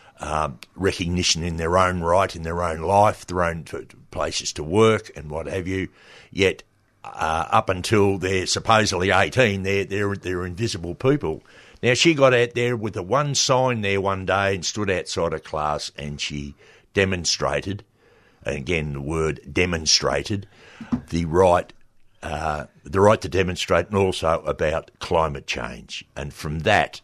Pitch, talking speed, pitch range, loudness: 95 Hz, 160 wpm, 85-105 Hz, -22 LUFS